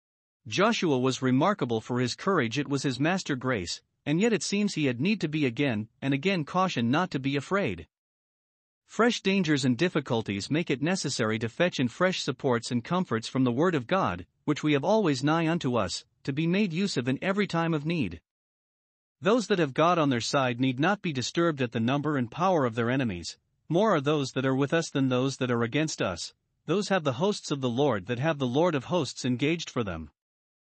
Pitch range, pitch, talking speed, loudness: 125-170 Hz, 145 Hz, 220 wpm, -27 LUFS